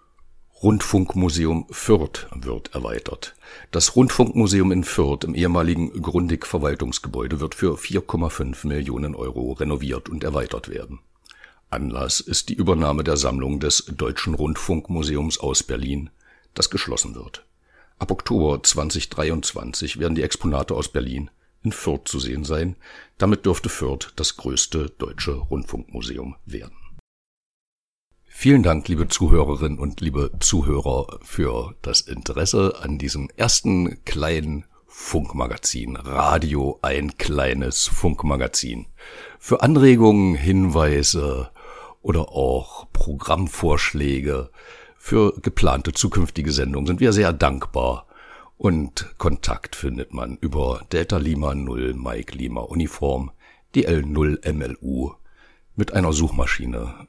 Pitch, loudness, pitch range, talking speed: 75 Hz, -22 LUFS, 70-90 Hz, 110 wpm